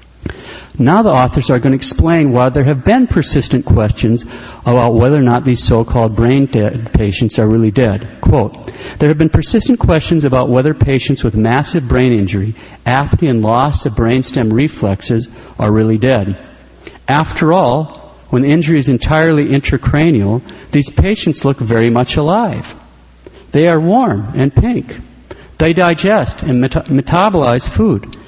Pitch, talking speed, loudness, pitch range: 125 Hz, 155 wpm, -12 LUFS, 115-150 Hz